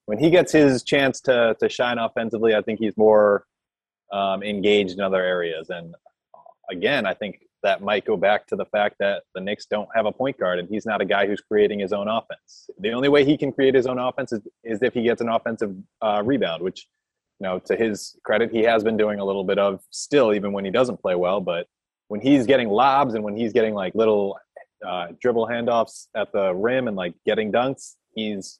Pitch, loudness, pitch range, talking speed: 105 Hz, -22 LUFS, 100-120 Hz, 225 wpm